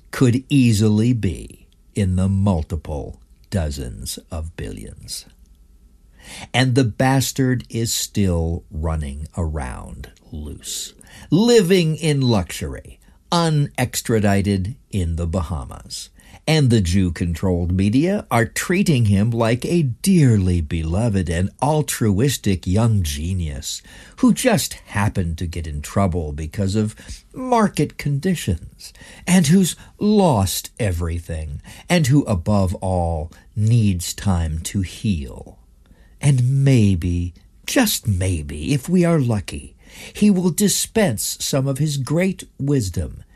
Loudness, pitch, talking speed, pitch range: -20 LUFS, 100 Hz, 110 wpm, 85-135 Hz